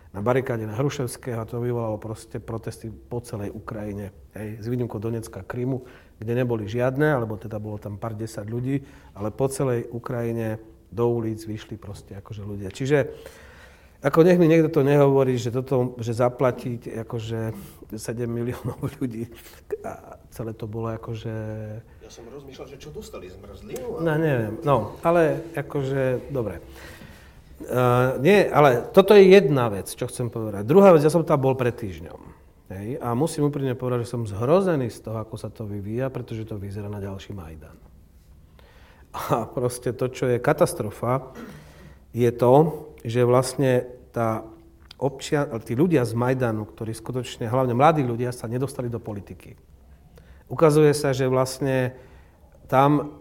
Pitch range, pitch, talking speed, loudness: 110-130 Hz, 120 Hz, 155 wpm, -23 LUFS